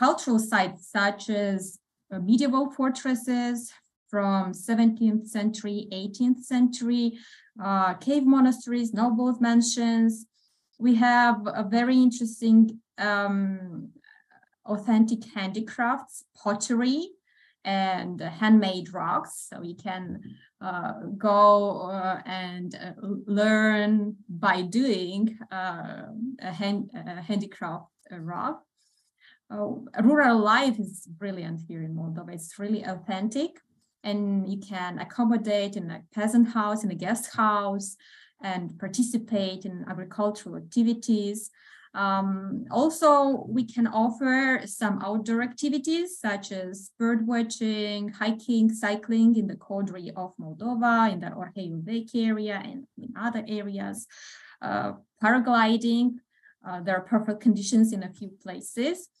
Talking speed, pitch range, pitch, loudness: 115 wpm, 195-240 Hz, 215 Hz, -26 LUFS